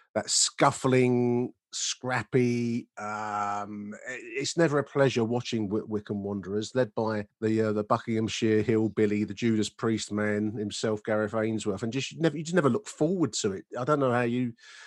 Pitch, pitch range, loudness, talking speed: 110 Hz, 105-125 Hz, -28 LUFS, 160 wpm